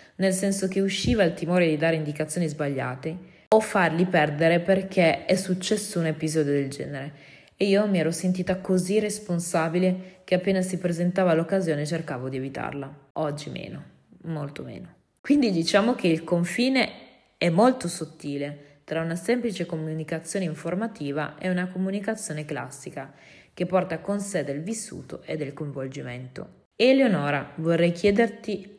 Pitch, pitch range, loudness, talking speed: 175 Hz, 155-195 Hz, -25 LUFS, 140 wpm